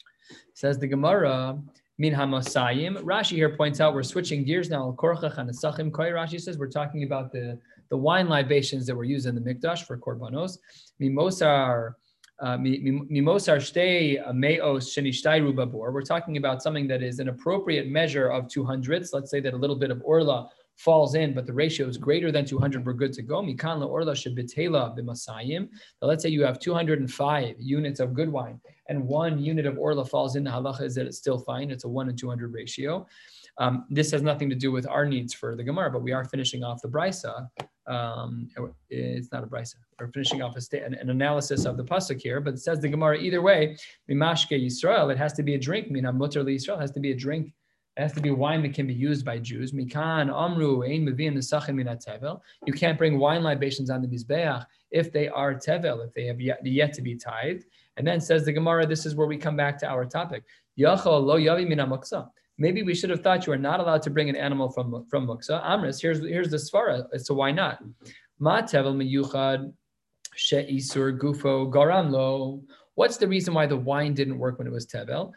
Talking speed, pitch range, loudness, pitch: 190 wpm, 130-155 Hz, -26 LUFS, 140 Hz